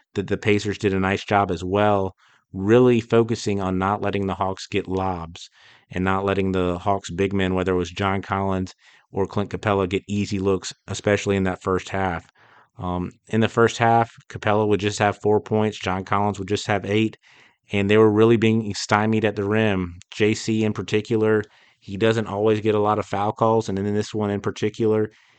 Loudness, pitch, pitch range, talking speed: -22 LUFS, 100 Hz, 95-110 Hz, 200 wpm